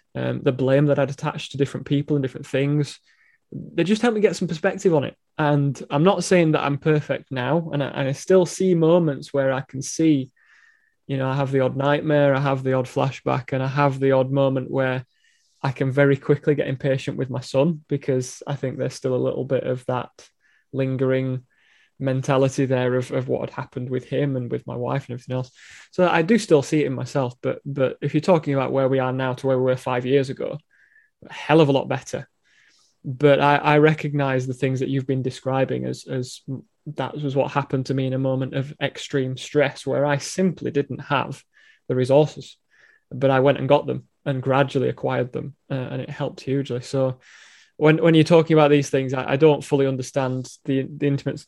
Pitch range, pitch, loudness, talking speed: 130-150 Hz, 140 Hz, -22 LUFS, 220 wpm